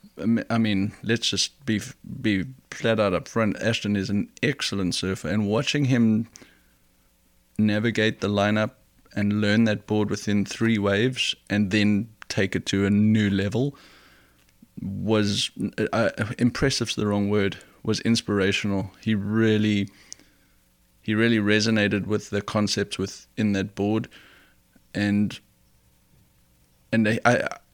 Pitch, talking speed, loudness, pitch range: 105 Hz, 130 wpm, -24 LUFS, 100-110 Hz